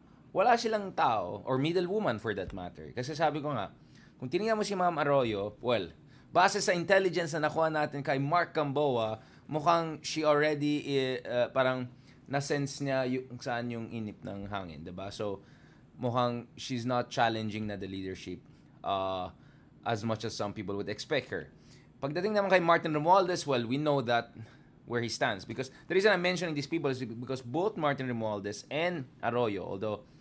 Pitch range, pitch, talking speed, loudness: 115-155 Hz, 130 Hz, 175 wpm, -31 LUFS